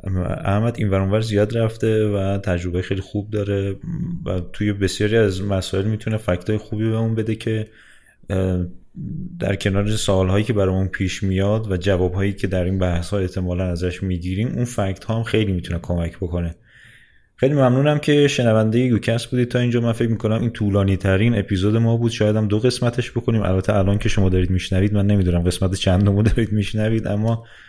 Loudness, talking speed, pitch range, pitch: -20 LUFS, 180 wpm, 95-115 Hz, 105 Hz